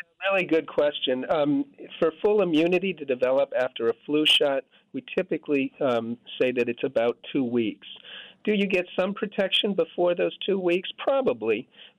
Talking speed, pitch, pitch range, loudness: 160 wpm, 175 Hz, 140-200 Hz, -25 LUFS